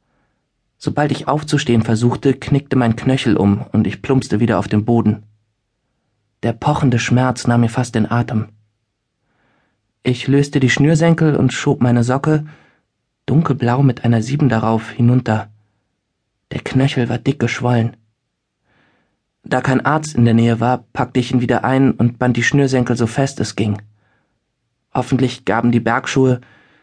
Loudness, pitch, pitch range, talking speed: -16 LUFS, 120 Hz, 115-135 Hz, 150 wpm